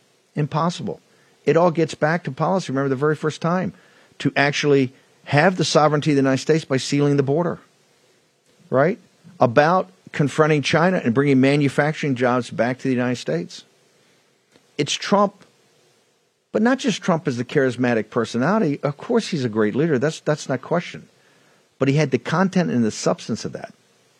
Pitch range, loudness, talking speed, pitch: 135-165 Hz, -20 LUFS, 170 wpm, 150 Hz